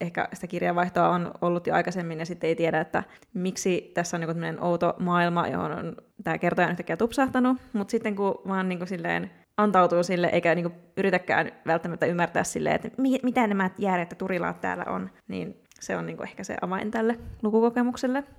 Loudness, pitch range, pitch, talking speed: -27 LUFS, 170-210 Hz, 180 Hz, 185 wpm